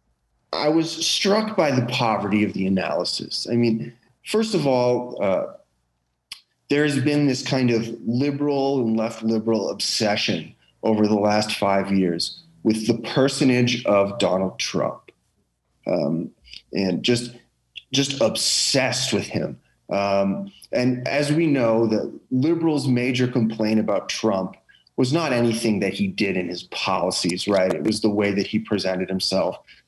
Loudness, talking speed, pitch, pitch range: -22 LUFS, 145 wpm, 115 Hz, 100-130 Hz